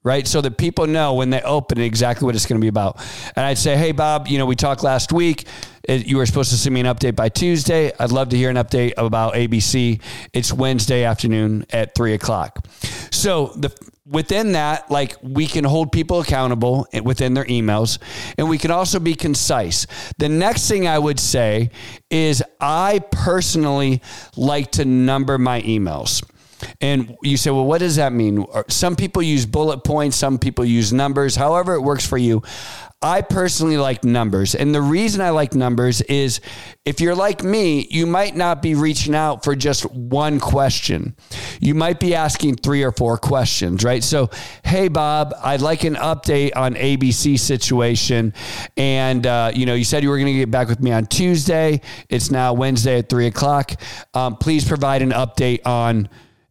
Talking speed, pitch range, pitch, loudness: 190 wpm, 120-150 Hz, 135 Hz, -18 LUFS